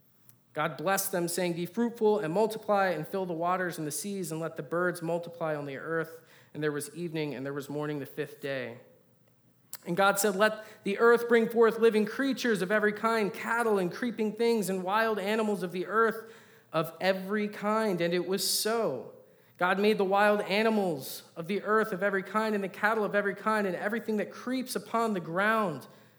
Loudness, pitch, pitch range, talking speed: -29 LUFS, 200 Hz, 170-220 Hz, 200 wpm